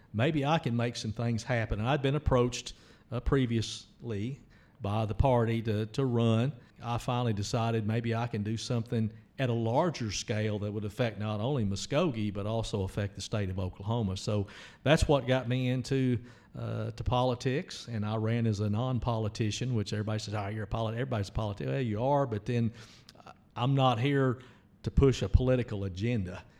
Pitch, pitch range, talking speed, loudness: 115 Hz, 105-125 Hz, 185 wpm, -31 LUFS